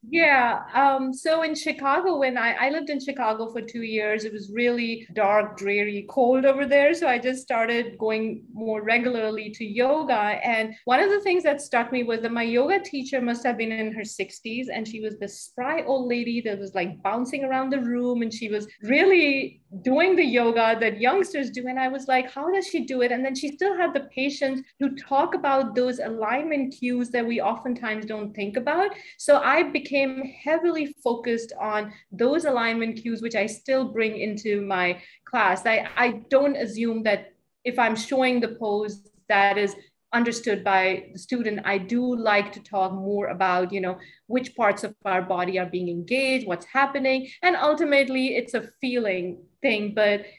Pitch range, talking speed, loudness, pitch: 210-270 Hz, 190 wpm, -24 LUFS, 235 Hz